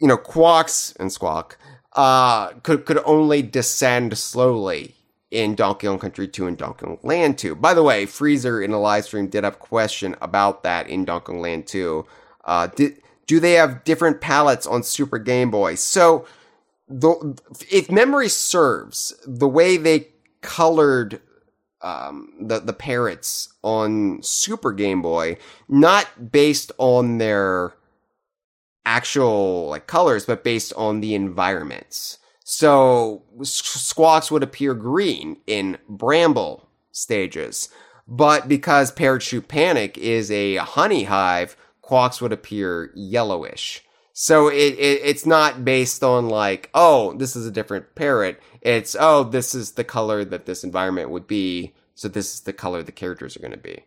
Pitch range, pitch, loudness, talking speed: 105-150 Hz, 125 Hz, -19 LUFS, 150 wpm